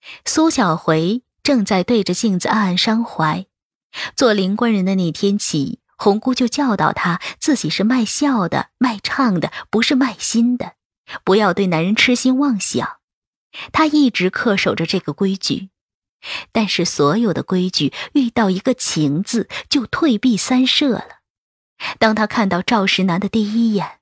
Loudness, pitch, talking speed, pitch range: -17 LUFS, 215 Hz, 225 characters per minute, 190-255 Hz